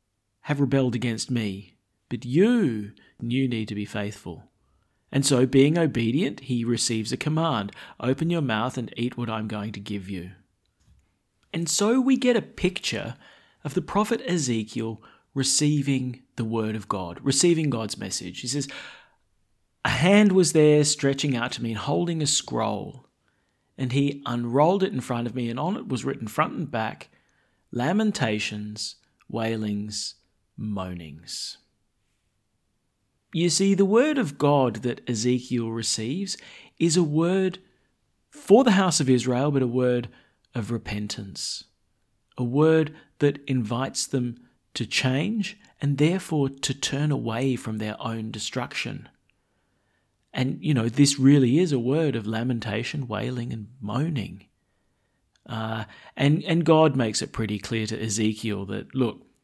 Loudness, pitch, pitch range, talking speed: -25 LUFS, 125 Hz, 110-145 Hz, 145 wpm